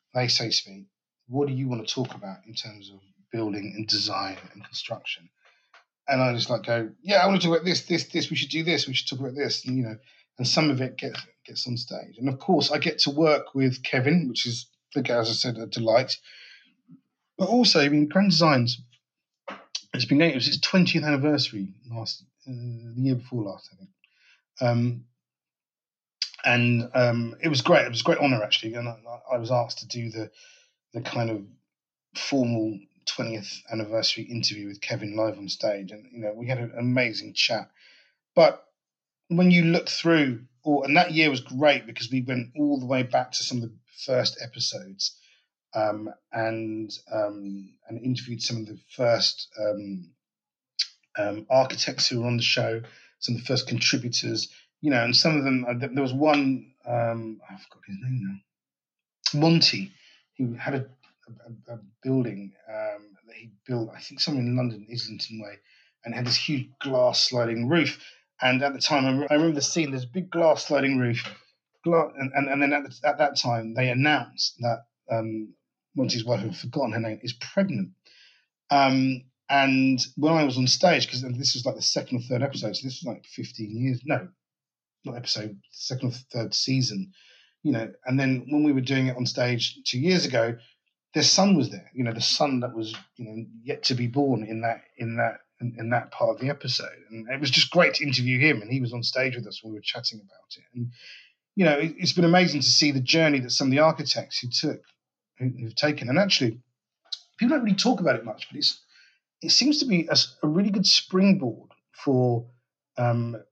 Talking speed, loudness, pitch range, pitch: 205 wpm, -24 LUFS, 115-145 Hz, 125 Hz